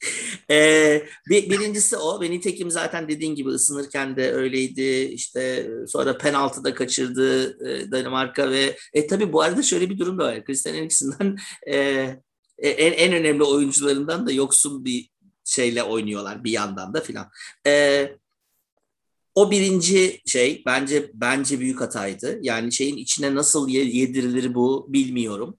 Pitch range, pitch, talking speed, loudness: 130-165 Hz, 140 Hz, 140 wpm, -21 LUFS